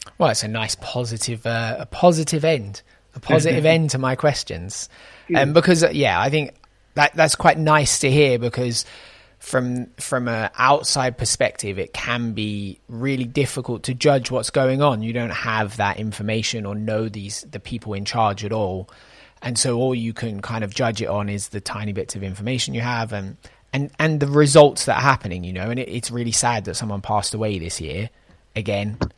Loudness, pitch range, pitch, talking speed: -20 LUFS, 105-135 Hz, 115 Hz, 200 wpm